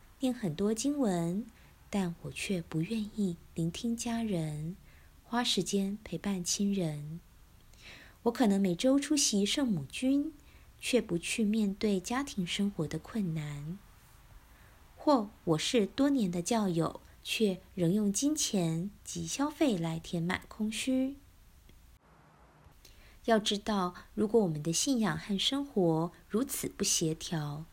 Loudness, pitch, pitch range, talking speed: -32 LUFS, 200 Hz, 170-235 Hz, 180 characters per minute